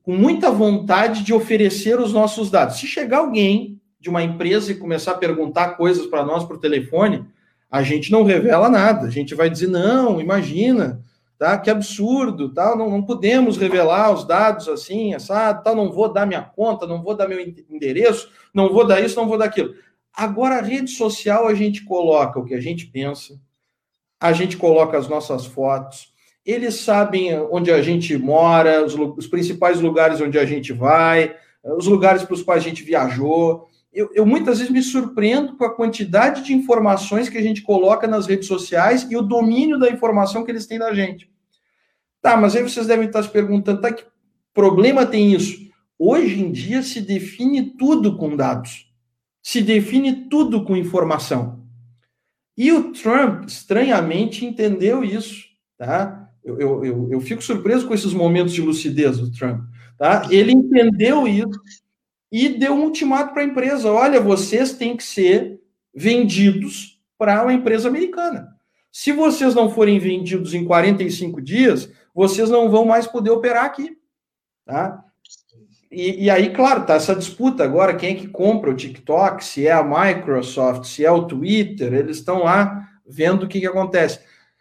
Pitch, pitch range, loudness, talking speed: 200 Hz, 170-230 Hz, -18 LUFS, 175 wpm